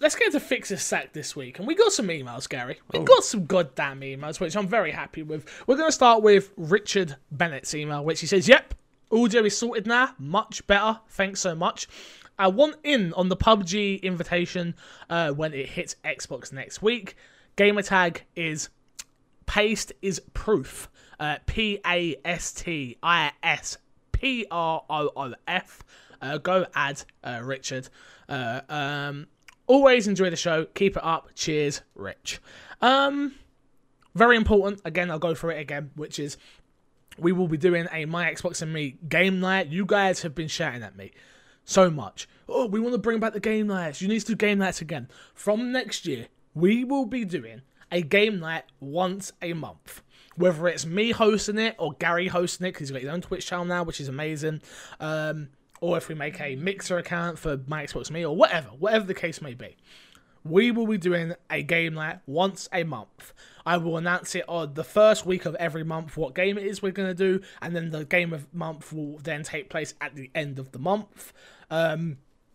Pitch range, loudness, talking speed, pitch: 155-200 Hz, -25 LUFS, 190 wpm, 175 Hz